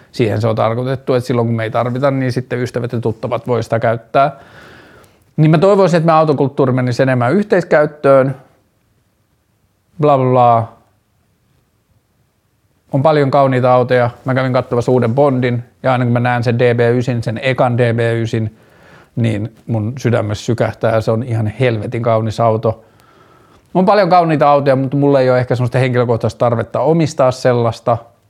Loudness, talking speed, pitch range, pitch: -14 LUFS, 155 wpm, 115-130 Hz, 120 Hz